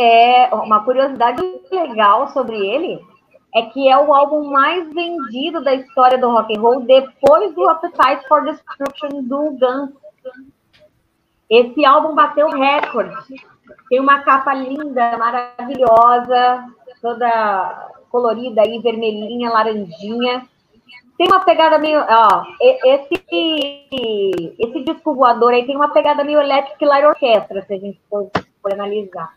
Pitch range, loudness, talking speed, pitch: 230-295 Hz, -15 LUFS, 130 wpm, 260 Hz